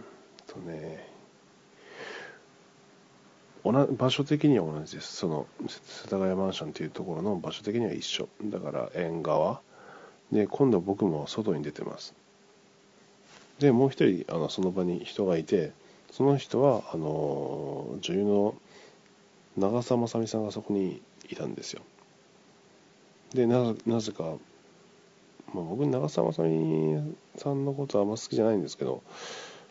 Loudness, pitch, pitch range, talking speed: -29 LUFS, 105 Hz, 85-130 Hz, 250 characters per minute